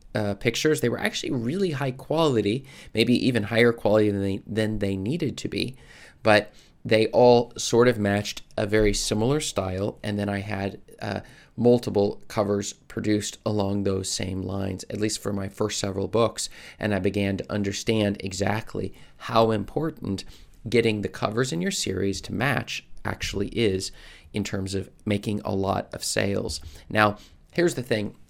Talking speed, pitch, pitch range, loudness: 165 wpm, 105 Hz, 100-115 Hz, -25 LUFS